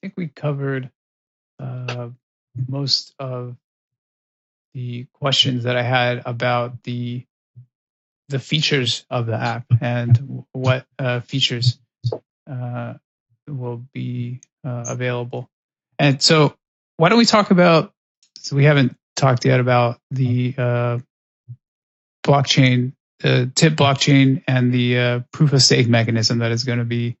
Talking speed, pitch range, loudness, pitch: 130 wpm, 120-135 Hz, -18 LUFS, 125 Hz